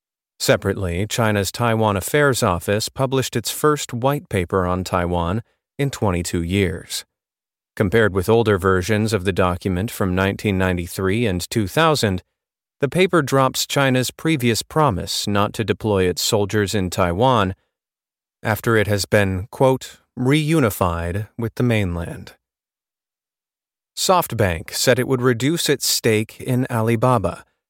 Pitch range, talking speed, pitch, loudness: 95-125 Hz, 125 wpm, 110 Hz, -19 LUFS